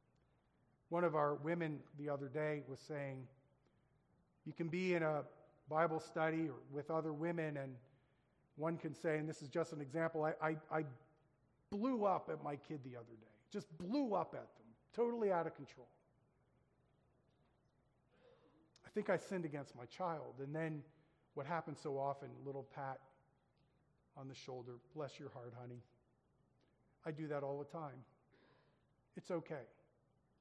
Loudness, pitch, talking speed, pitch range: -43 LUFS, 145 Hz, 160 wpm, 135-160 Hz